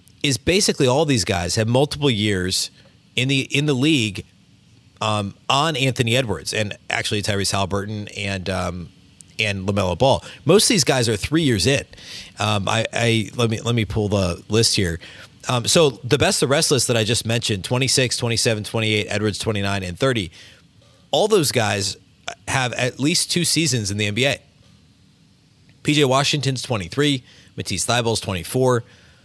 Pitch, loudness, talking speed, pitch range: 115 Hz, -20 LUFS, 165 wpm, 100-130 Hz